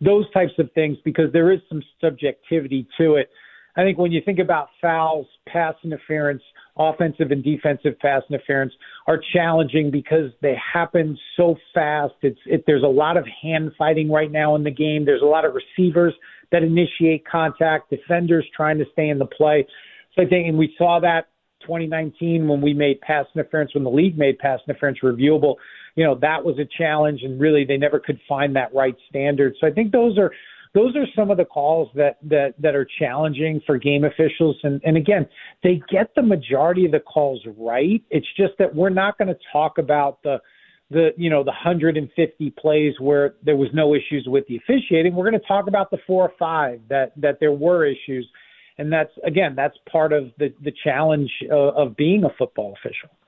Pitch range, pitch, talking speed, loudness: 145-170 Hz, 155 Hz, 200 wpm, -20 LUFS